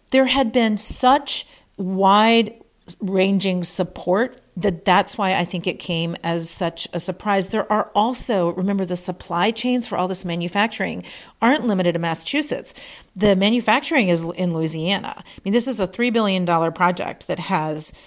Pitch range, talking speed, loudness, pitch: 175-225 Hz, 160 wpm, -19 LUFS, 195 Hz